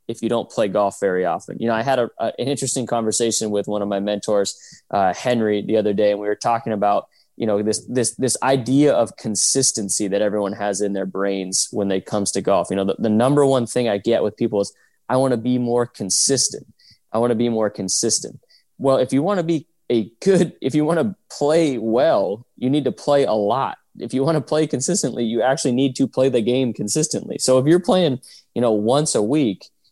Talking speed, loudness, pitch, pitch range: 235 wpm, -20 LUFS, 120 Hz, 105-135 Hz